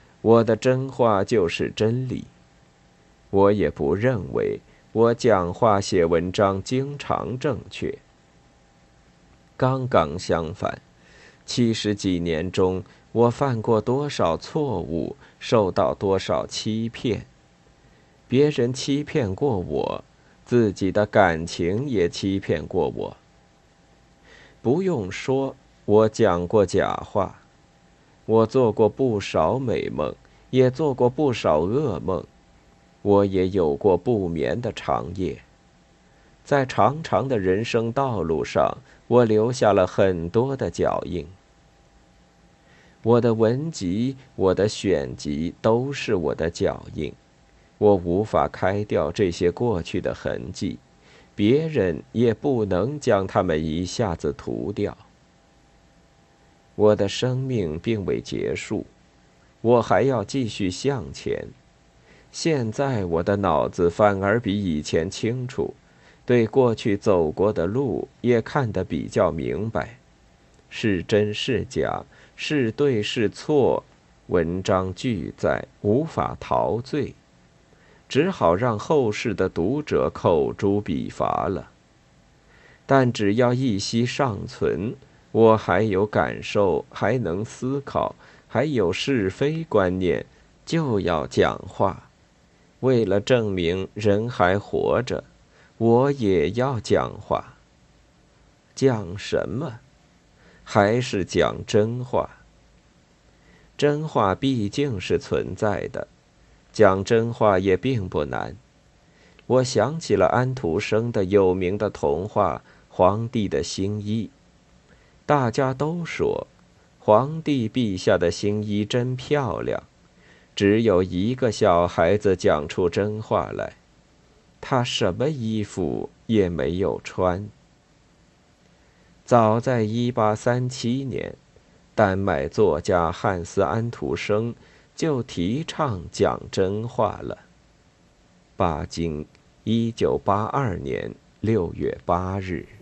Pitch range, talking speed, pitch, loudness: 90-125 Hz, 155 characters per minute, 105 Hz, -23 LUFS